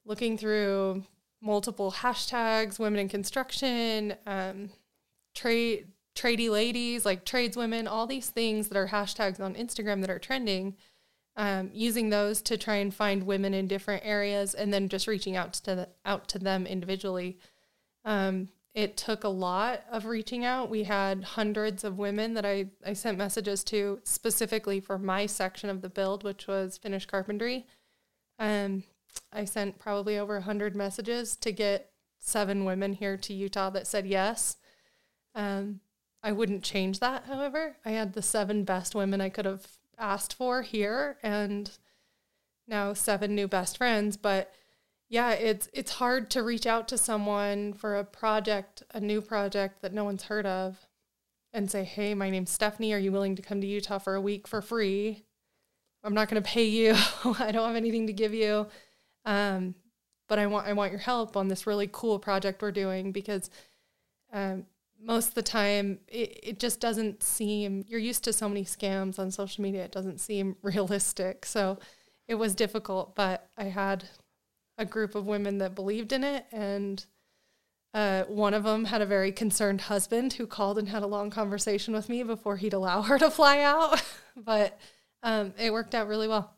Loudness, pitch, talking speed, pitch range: -30 LUFS, 205 Hz, 180 wpm, 195-220 Hz